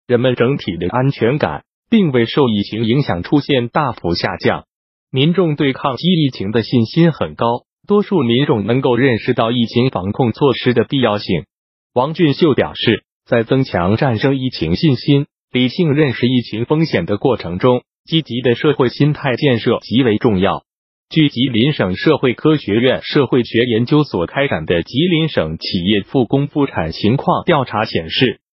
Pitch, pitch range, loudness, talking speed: 130 Hz, 115-150 Hz, -16 LUFS, 260 characters per minute